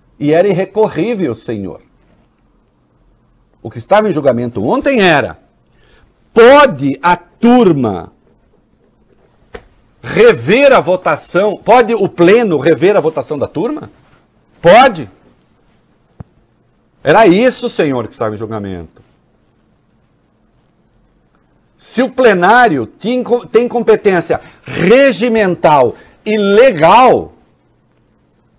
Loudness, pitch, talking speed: -10 LUFS, 200 Hz, 90 wpm